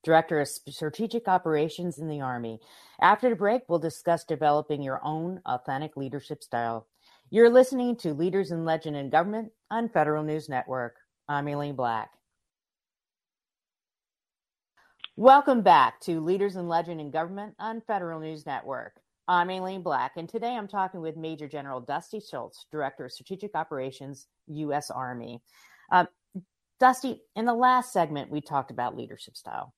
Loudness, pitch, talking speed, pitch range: -27 LUFS, 160 Hz, 150 wpm, 145-195 Hz